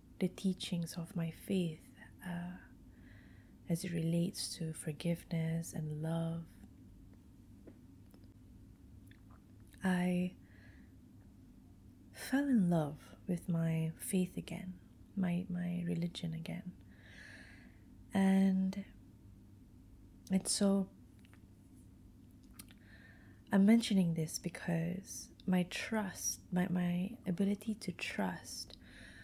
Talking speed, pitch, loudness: 80 wpm, 170 Hz, -37 LUFS